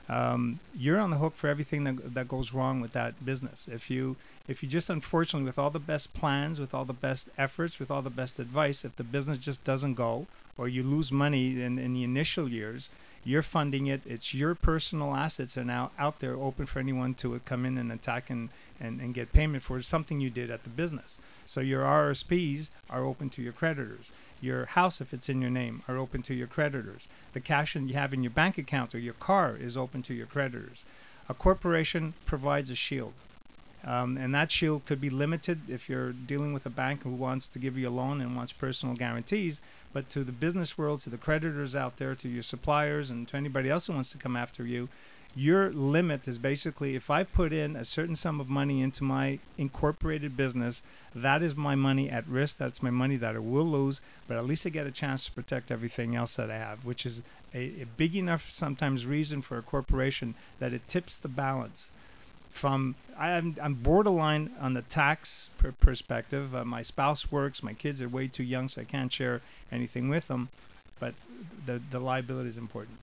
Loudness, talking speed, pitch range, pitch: -32 LUFS, 215 wpm, 125-150 Hz, 135 Hz